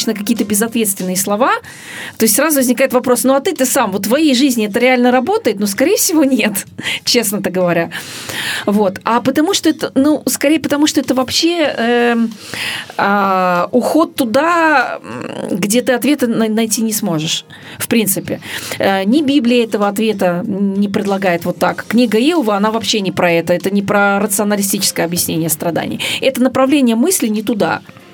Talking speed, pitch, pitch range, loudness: 155 wpm, 230 Hz, 200-265 Hz, -14 LUFS